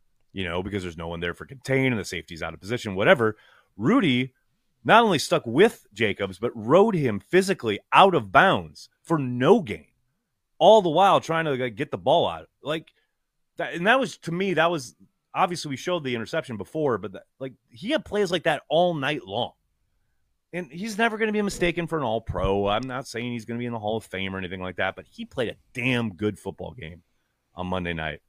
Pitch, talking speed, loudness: 120 Hz, 225 wpm, -24 LUFS